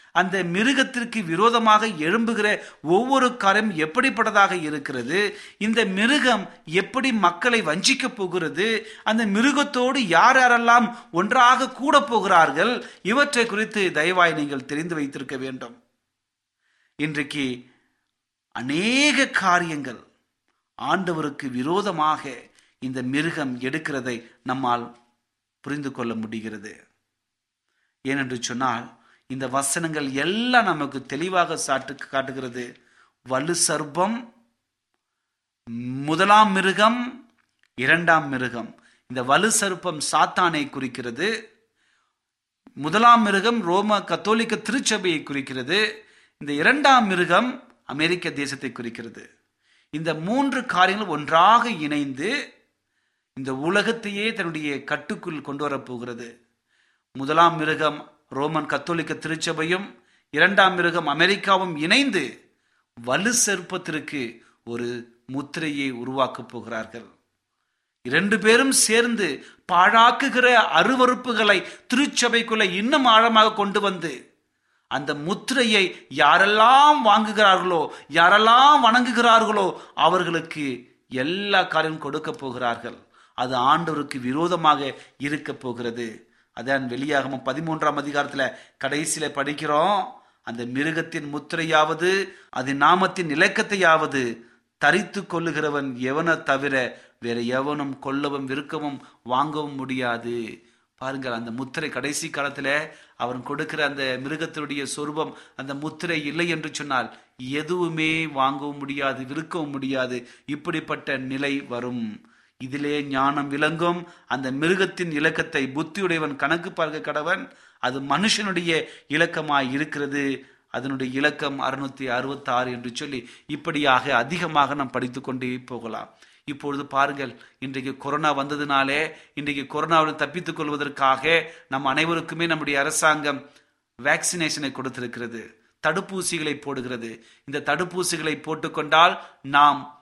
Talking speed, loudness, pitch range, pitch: 95 wpm, -22 LUFS, 135-190 Hz, 155 Hz